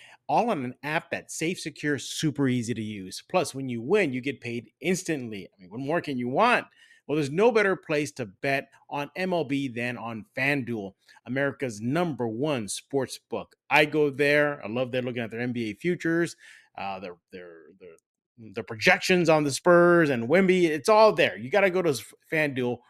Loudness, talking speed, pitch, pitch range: -26 LUFS, 190 wpm, 145 Hz, 120-170 Hz